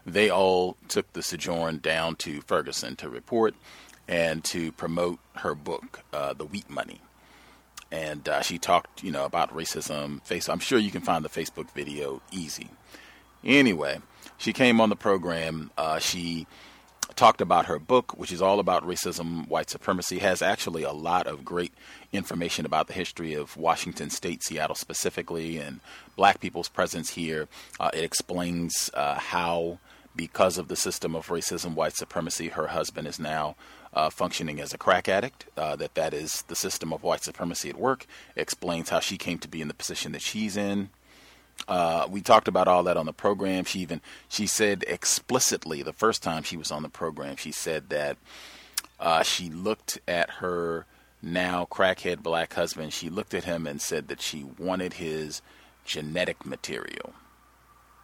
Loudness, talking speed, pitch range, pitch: -28 LUFS, 175 wpm, 80-90 Hz, 85 Hz